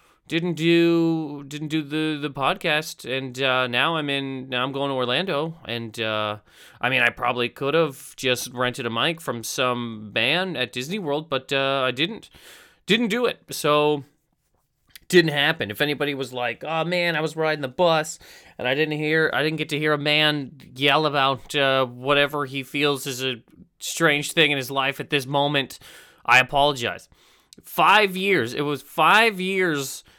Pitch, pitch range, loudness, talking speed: 145 Hz, 130-155 Hz, -22 LUFS, 180 wpm